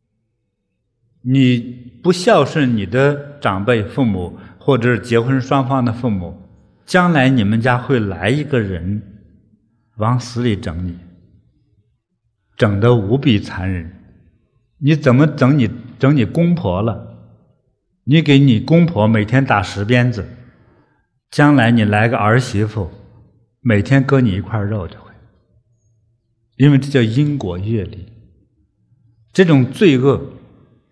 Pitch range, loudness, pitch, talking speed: 105-135 Hz, -15 LUFS, 115 Hz, 175 characters per minute